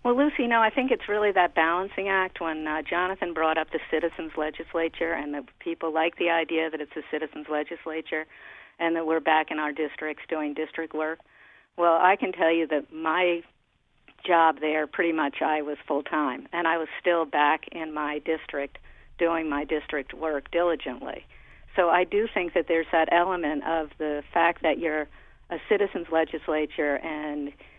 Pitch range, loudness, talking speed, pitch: 155-170 Hz, -26 LUFS, 180 wpm, 160 Hz